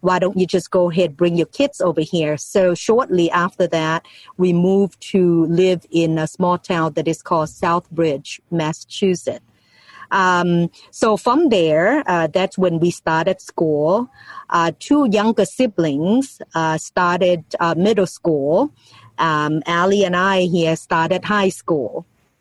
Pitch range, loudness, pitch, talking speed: 165-190 Hz, -18 LUFS, 175 Hz, 145 wpm